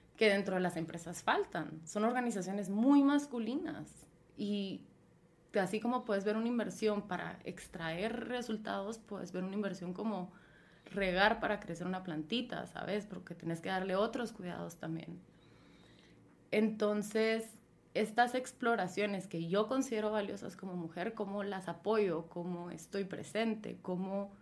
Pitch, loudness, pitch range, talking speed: 200 Hz, -37 LUFS, 180-220 Hz, 135 wpm